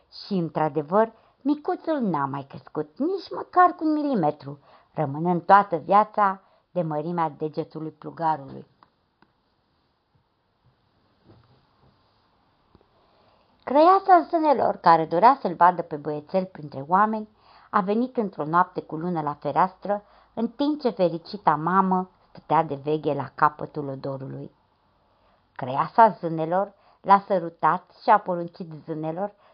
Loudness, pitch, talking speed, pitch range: -23 LUFS, 180 Hz, 110 wpm, 155-210 Hz